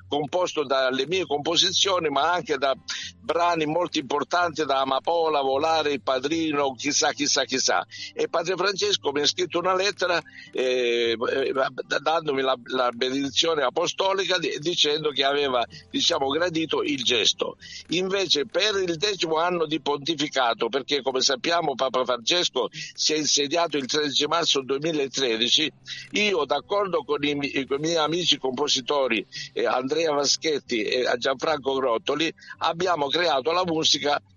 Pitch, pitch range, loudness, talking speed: 150 Hz, 135-175 Hz, -23 LUFS, 140 wpm